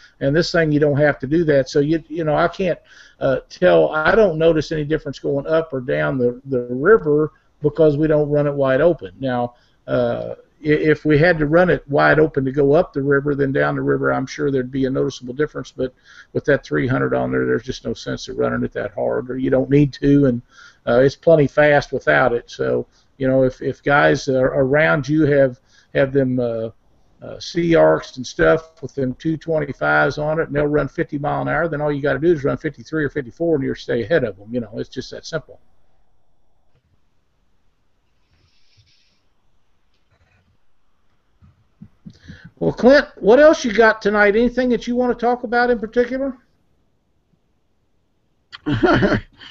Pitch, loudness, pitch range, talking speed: 140 Hz, -18 LUFS, 120-160 Hz, 200 wpm